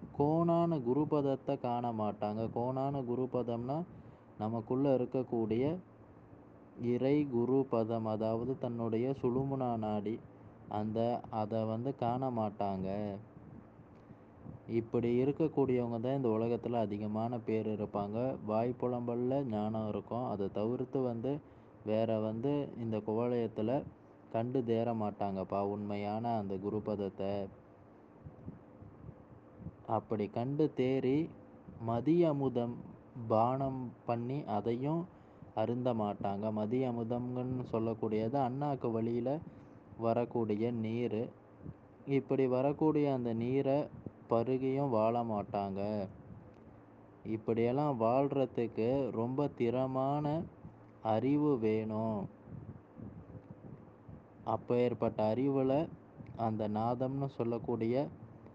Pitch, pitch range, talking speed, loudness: 120 Hz, 110-130 Hz, 80 wpm, -35 LUFS